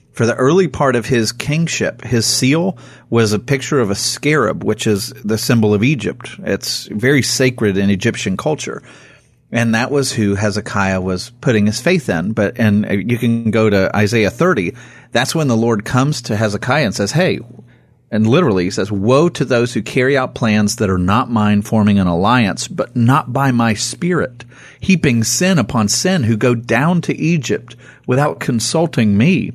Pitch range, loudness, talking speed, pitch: 105-135 Hz, -15 LUFS, 185 wpm, 120 Hz